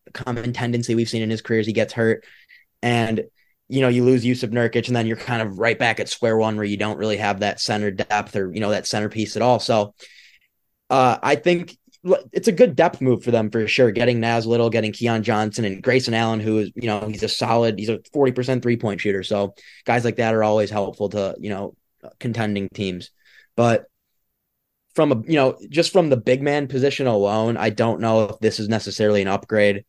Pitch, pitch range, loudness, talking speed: 115 Hz, 105-125 Hz, -21 LUFS, 225 wpm